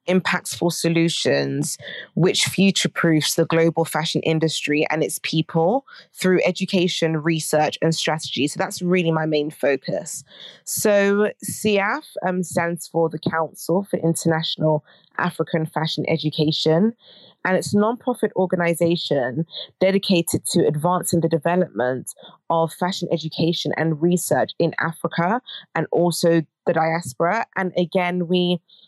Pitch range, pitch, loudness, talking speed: 160-180 Hz, 165 Hz, -21 LUFS, 125 wpm